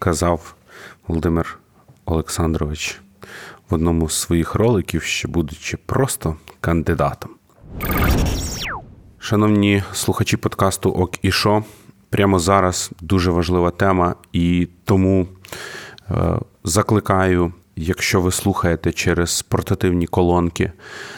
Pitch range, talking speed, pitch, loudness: 85-100 Hz, 90 wpm, 90 Hz, -19 LUFS